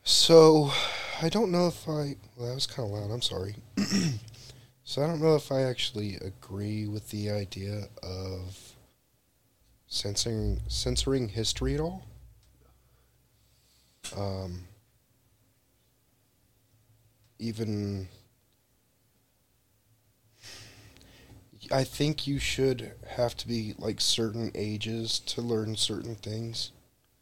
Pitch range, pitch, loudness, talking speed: 105-125 Hz, 115 Hz, -29 LUFS, 105 wpm